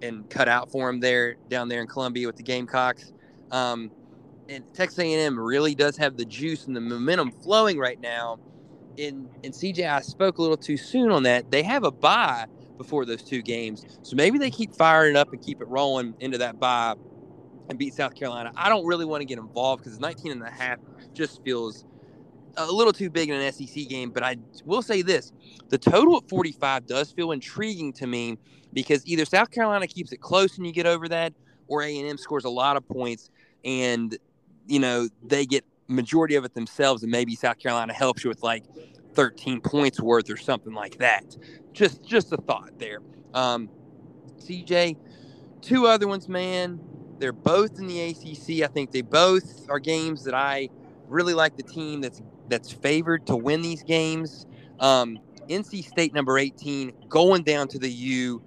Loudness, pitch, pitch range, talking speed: -24 LUFS, 140 Hz, 125-160 Hz, 195 wpm